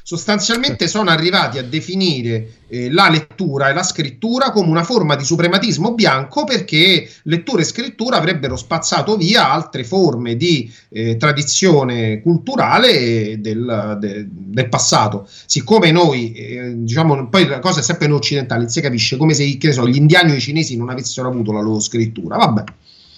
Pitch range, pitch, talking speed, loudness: 120-175 Hz, 150 Hz, 165 wpm, -15 LUFS